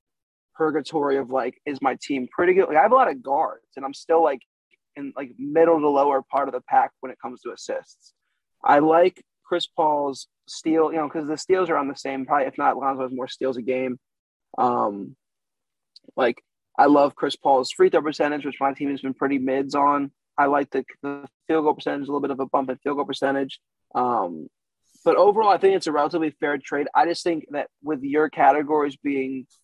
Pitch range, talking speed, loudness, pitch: 135-160 Hz, 220 wpm, -22 LUFS, 145 Hz